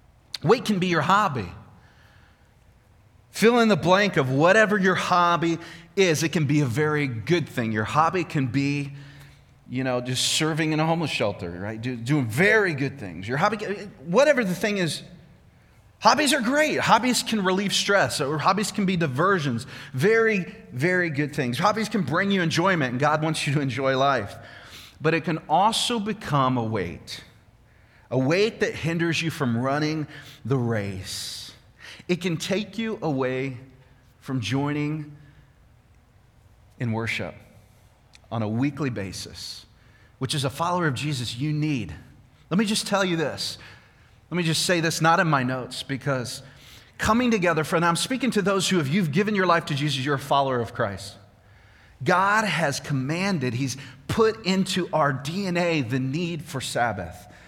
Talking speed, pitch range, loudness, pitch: 165 wpm, 120-175 Hz, -23 LUFS, 145 Hz